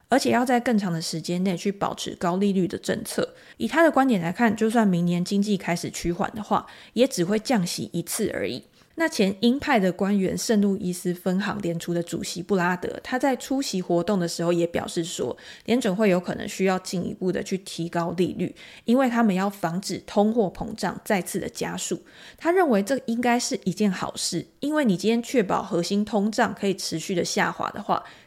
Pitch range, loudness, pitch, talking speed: 175-230 Hz, -25 LUFS, 195 Hz, 310 characters per minute